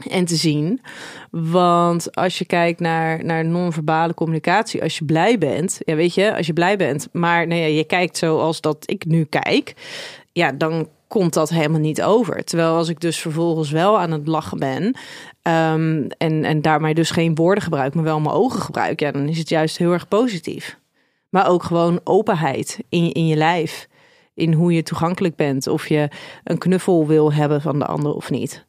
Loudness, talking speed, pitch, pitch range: -19 LUFS, 200 wpm, 165 Hz, 155-175 Hz